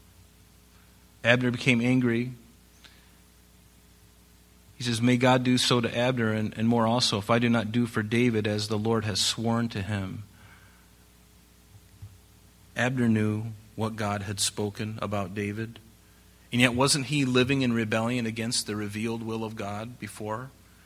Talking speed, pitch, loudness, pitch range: 145 wpm, 110 Hz, -26 LUFS, 100-120 Hz